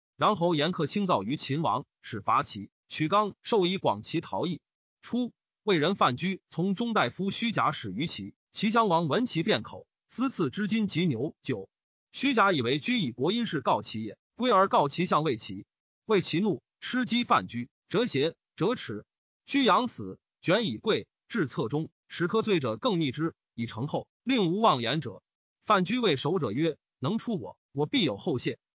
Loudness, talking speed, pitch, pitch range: -28 LUFS, 240 characters per minute, 175 Hz, 150-215 Hz